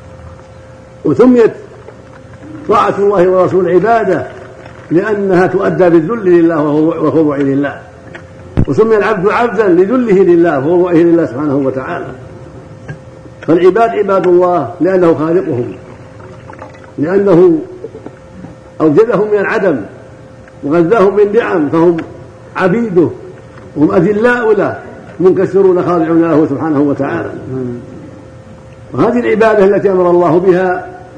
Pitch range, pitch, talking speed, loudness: 130-195 Hz, 170 Hz, 90 wpm, -10 LUFS